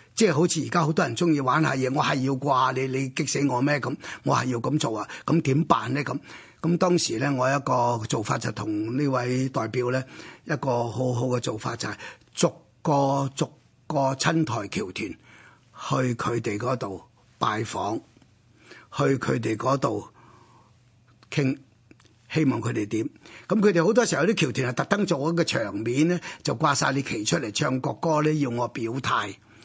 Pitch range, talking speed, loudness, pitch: 120-155 Hz, 245 characters per minute, -25 LUFS, 135 Hz